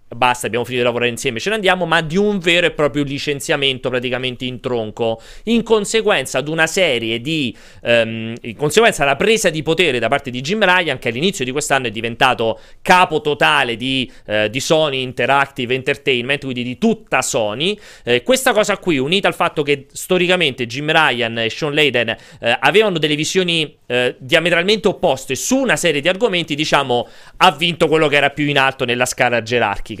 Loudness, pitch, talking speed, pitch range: -16 LUFS, 145 Hz, 185 wpm, 125-175 Hz